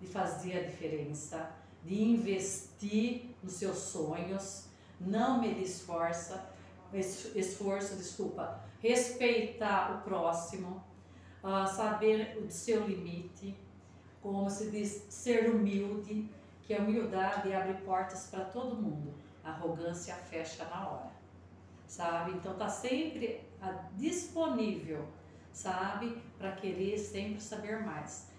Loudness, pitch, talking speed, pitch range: -36 LUFS, 190 Hz, 110 wpm, 170-215 Hz